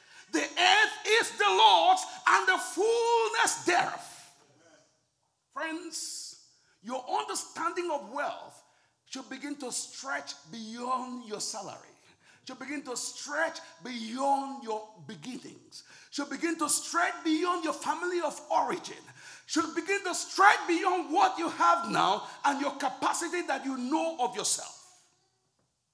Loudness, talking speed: -28 LUFS, 125 wpm